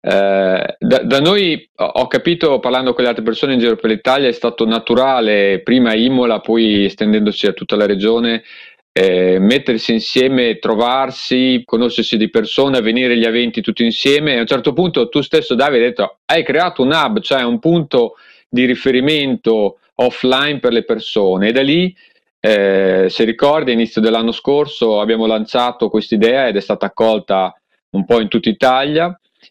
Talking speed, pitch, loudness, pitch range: 170 wpm, 115 Hz, -14 LUFS, 110-130 Hz